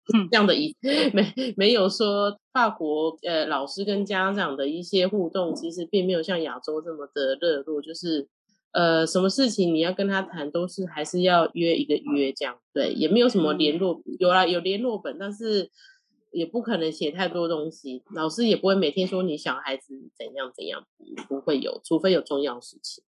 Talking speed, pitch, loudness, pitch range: 280 characters per minute, 180 Hz, -25 LUFS, 155-200 Hz